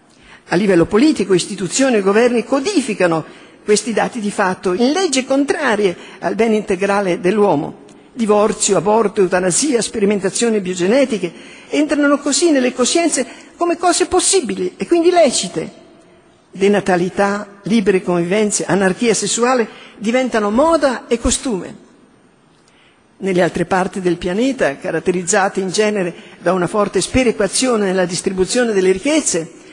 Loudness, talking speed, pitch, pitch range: -16 LUFS, 115 wpm, 210 Hz, 190-255 Hz